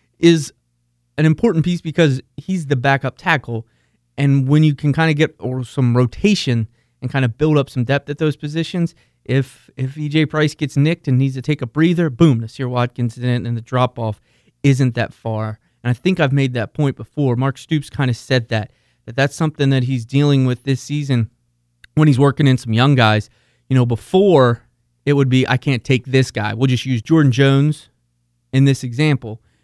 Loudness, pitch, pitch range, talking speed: -17 LUFS, 135 Hz, 120-150 Hz, 205 wpm